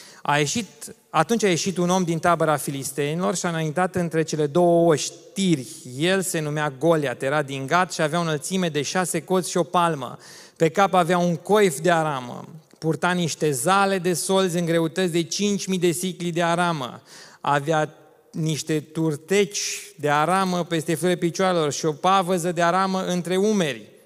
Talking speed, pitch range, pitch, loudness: 170 wpm, 155-185 Hz, 170 Hz, -22 LUFS